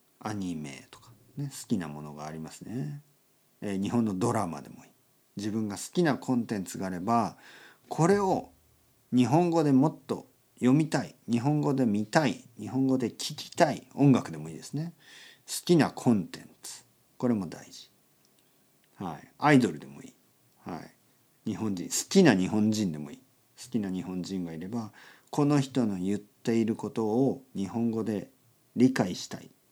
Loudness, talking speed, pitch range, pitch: -29 LUFS, 300 characters per minute, 100-135 Hz, 120 Hz